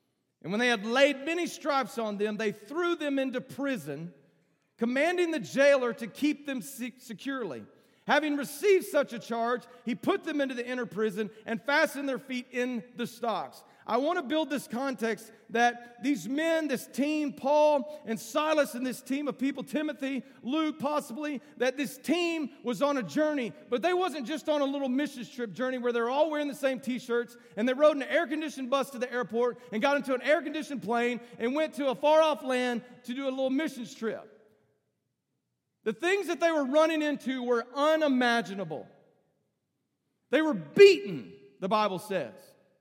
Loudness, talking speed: -29 LUFS, 180 wpm